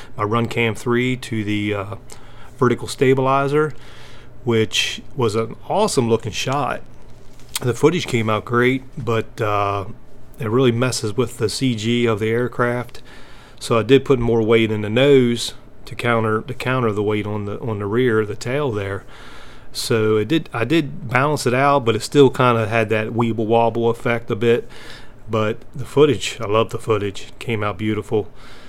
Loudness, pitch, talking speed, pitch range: -19 LUFS, 115 Hz, 175 wpm, 110-130 Hz